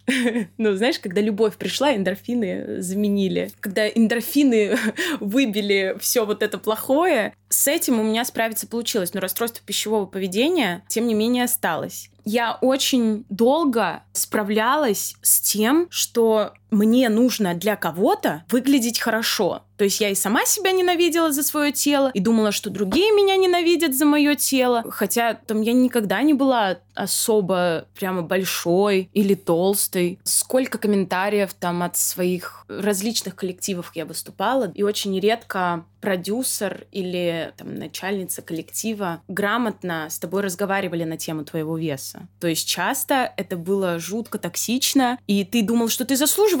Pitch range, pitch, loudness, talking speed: 190-245 Hz, 215 Hz, -21 LUFS, 140 wpm